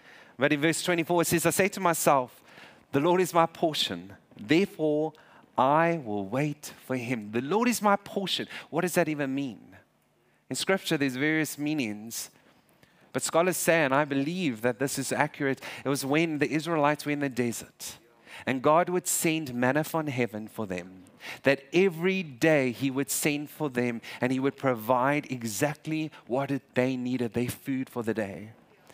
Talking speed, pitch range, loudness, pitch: 175 wpm, 130-165 Hz, -28 LUFS, 145 Hz